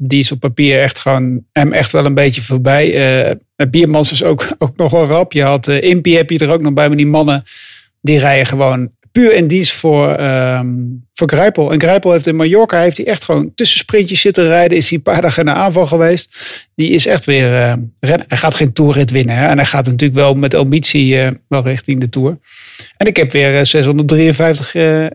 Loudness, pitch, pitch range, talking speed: -11 LUFS, 145 Hz, 135-165 Hz, 220 wpm